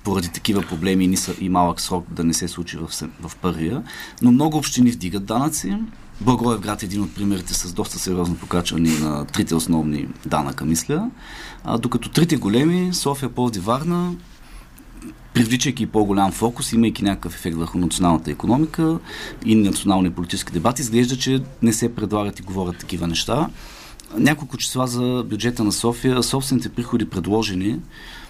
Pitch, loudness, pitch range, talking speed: 105 Hz, -21 LUFS, 90-125 Hz, 150 wpm